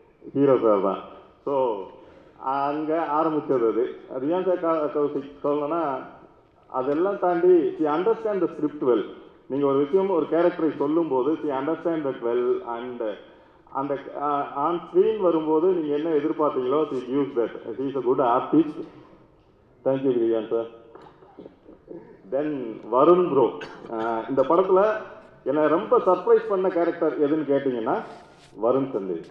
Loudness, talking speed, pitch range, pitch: -24 LUFS, 105 wpm, 140-215 Hz, 160 Hz